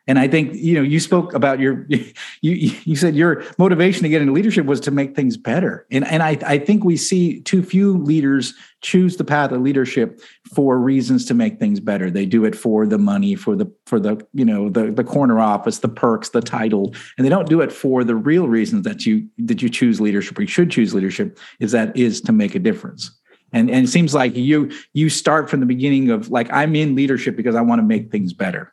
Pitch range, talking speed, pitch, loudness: 130-190 Hz, 240 wpm, 155 Hz, -17 LUFS